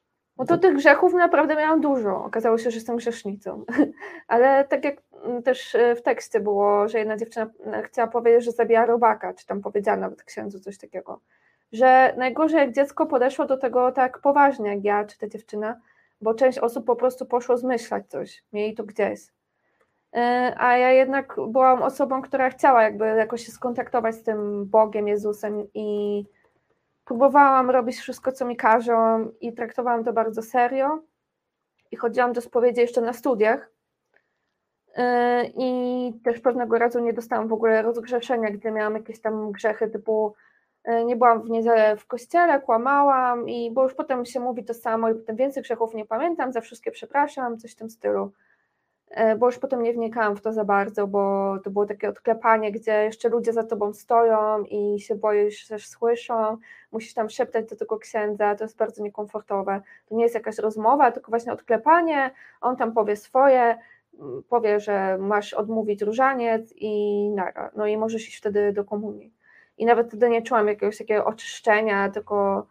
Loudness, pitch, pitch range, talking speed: -22 LUFS, 230 Hz, 215-255 Hz, 170 wpm